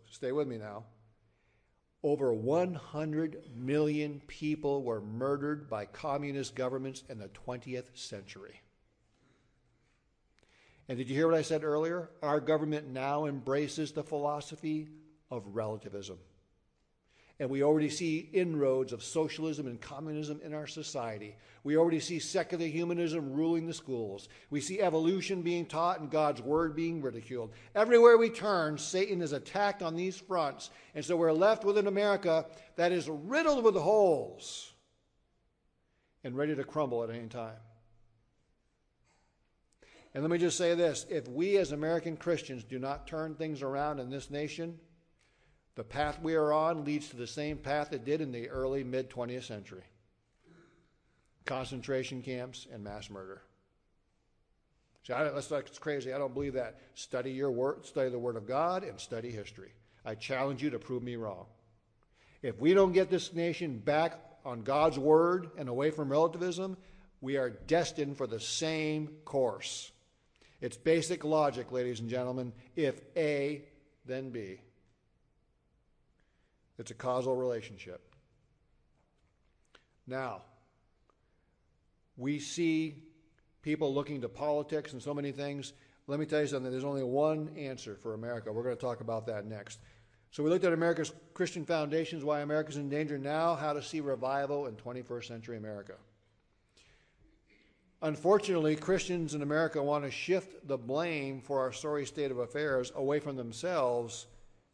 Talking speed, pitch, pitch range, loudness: 150 wpm, 145 Hz, 120-160 Hz, -33 LUFS